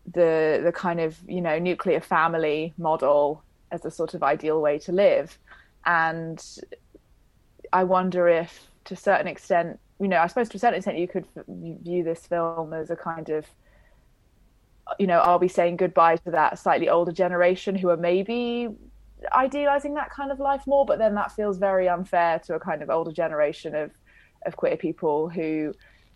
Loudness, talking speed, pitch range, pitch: -24 LUFS, 180 wpm, 160-190 Hz, 170 Hz